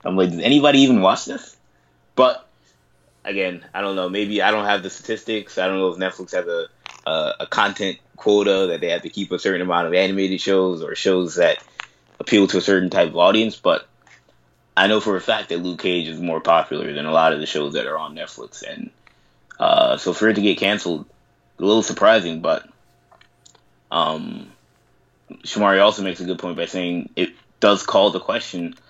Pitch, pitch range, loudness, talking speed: 95 Hz, 90-110 Hz, -19 LUFS, 205 wpm